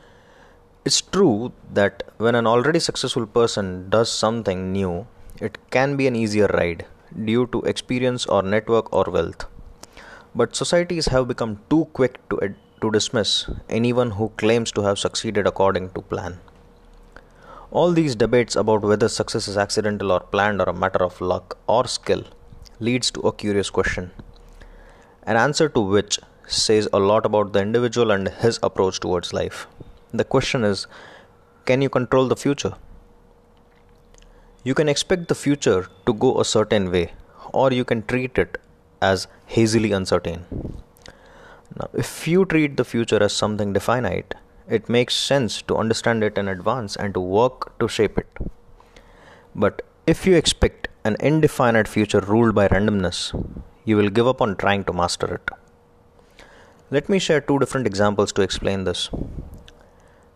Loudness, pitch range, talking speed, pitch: -21 LUFS, 95-125 Hz, 155 wpm, 110 Hz